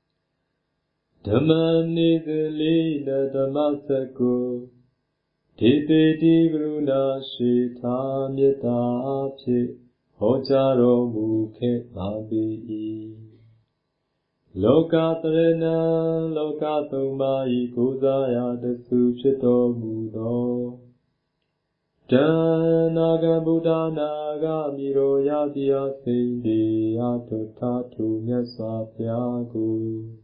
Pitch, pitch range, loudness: 135 Hz, 120-155 Hz, -23 LUFS